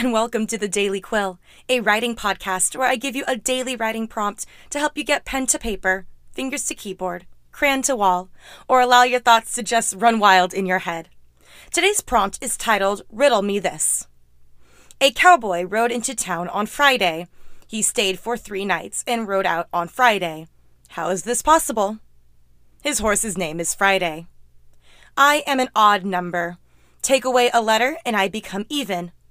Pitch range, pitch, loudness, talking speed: 185-255 Hz, 210 Hz, -20 LUFS, 180 wpm